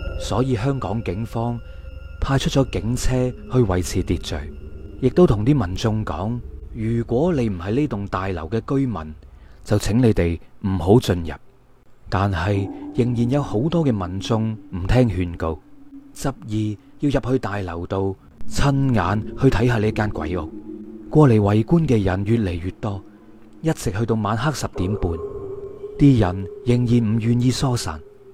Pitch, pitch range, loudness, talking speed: 110 Hz, 95-130 Hz, -21 LUFS, 215 characters per minute